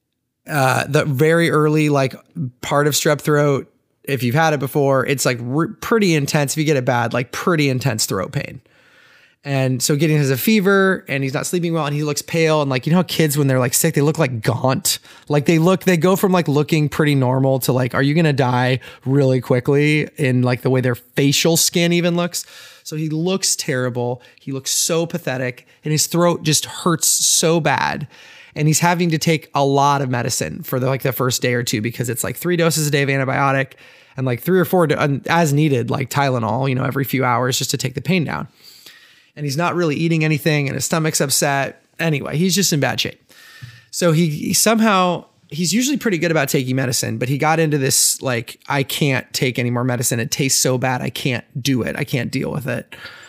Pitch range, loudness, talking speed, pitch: 130-165 Hz, -18 LUFS, 225 wpm, 145 Hz